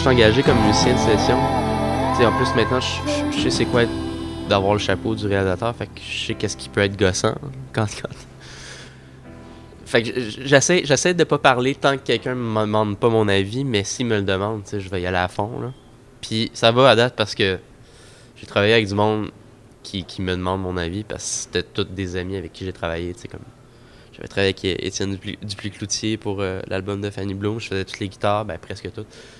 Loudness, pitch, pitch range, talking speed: -21 LUFS, 105 Hz, 95-115 Hz, 235 wpm